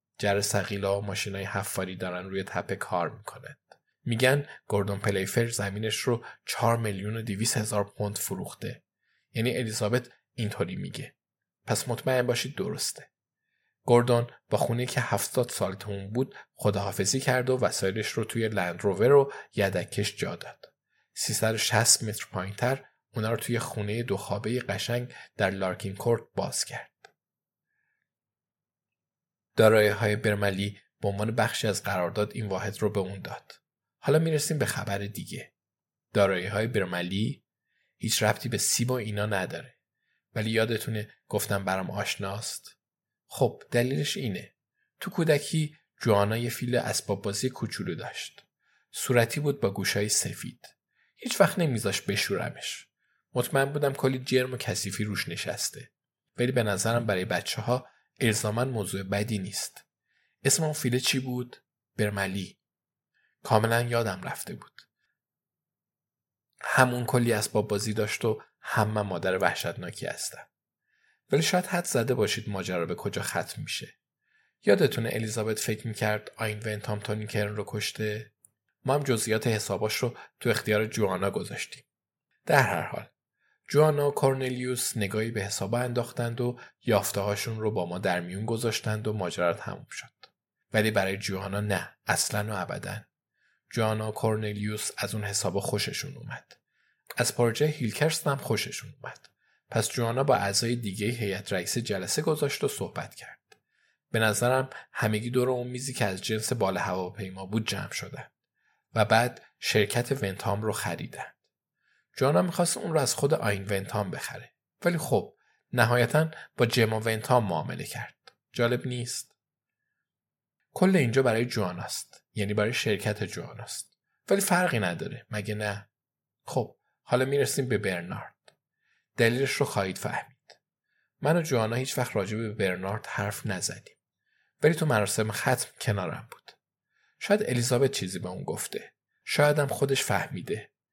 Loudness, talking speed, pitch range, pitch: -28 LUFS, 140 wpm, 100-125 Hz, 110 Hz